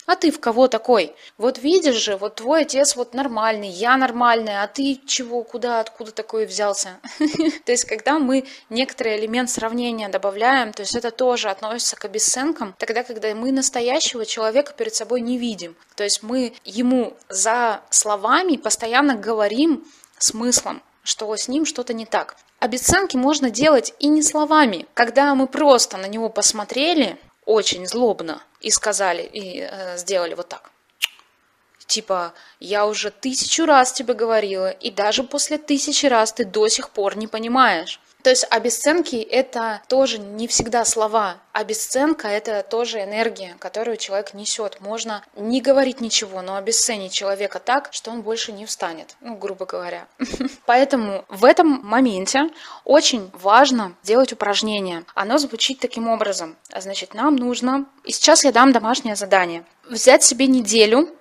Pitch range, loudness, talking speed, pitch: 210-265 Hz, -19 LUFS, 150 wpm, 235 Hz